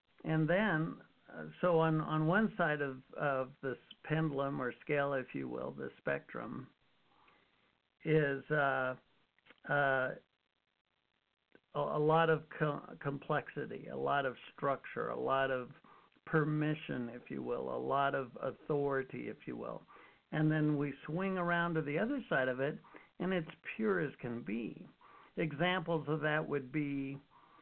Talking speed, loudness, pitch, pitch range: 145 wpm, -36 LUFS, 150 Hz, 135-160 Hz